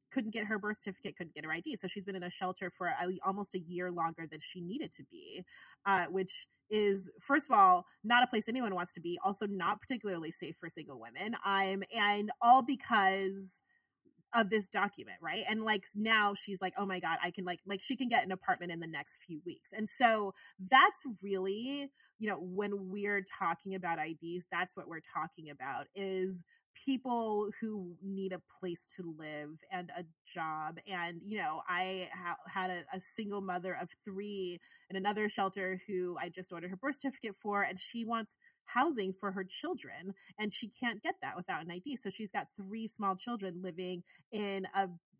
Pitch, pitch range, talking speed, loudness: 195 Hz, 180-220 Hz, 200 wpm, -30 LUFS